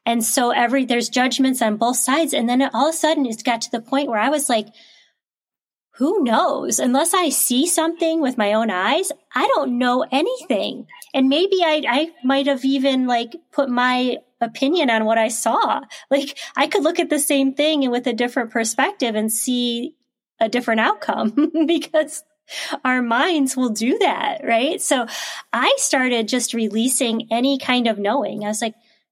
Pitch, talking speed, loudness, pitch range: 255 Hz, 185 wpm, -19 LUFS, 235-295 Hz